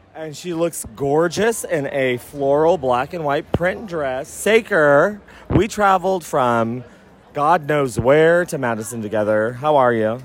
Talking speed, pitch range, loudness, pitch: 145 wpm, 125-175 Hz, -18 LUFS, 145 Hz